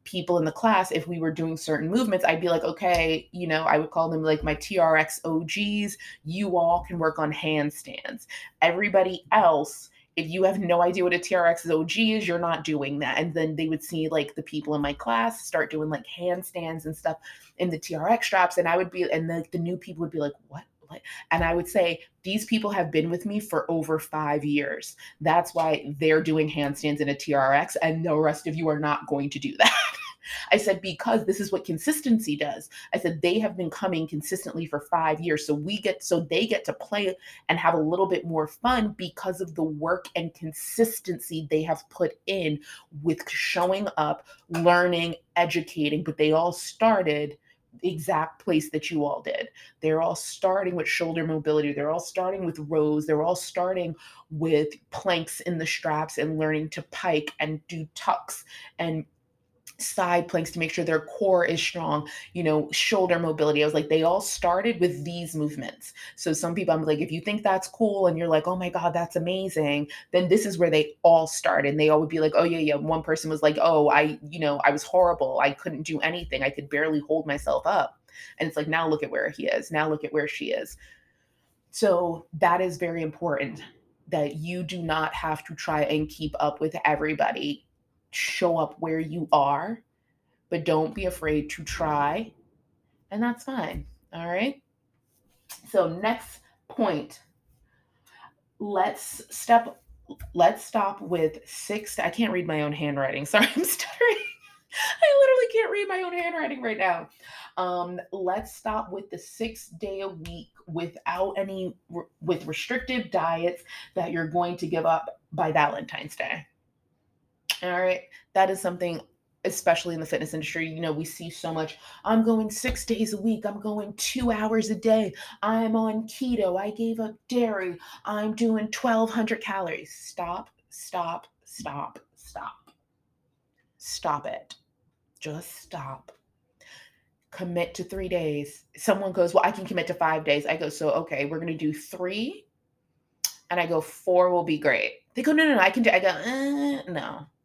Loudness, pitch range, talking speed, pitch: -26 LUFS, 155-190 Hz, 190 wpm, 170 Hz